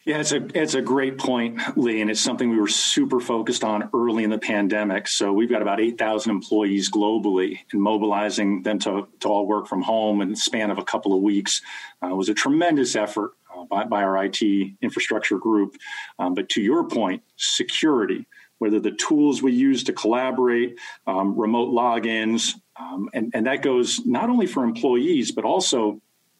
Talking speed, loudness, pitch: 190 wpm, -22 LUFS, 115 Hz